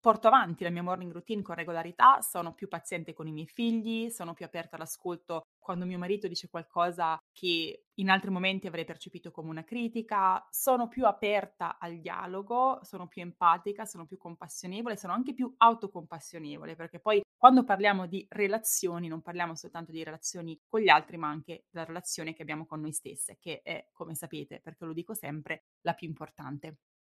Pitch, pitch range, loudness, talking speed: 175 Hz, 165-205 Hz, -30 LUFS, 180 wpm